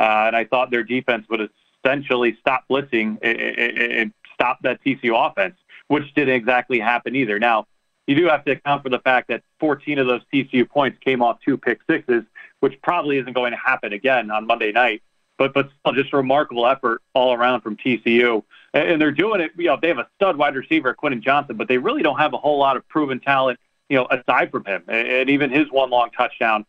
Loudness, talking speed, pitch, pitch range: -20 LUFS, 225 wpm, 130 Hz, 120-140 Hz